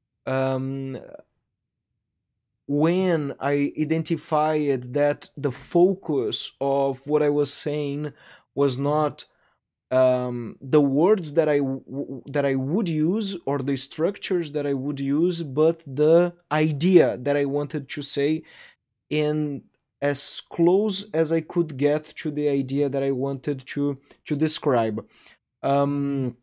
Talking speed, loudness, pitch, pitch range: 130 wpm, -24 LUFS, 145 Hz, 135-155 Hz